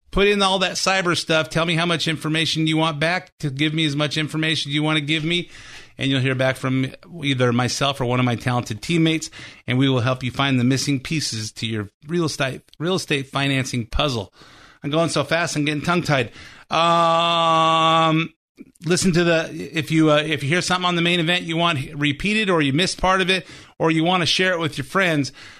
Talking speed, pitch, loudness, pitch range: 225 wpm, 160 Hz, -20 LUFS, 135-170 Hz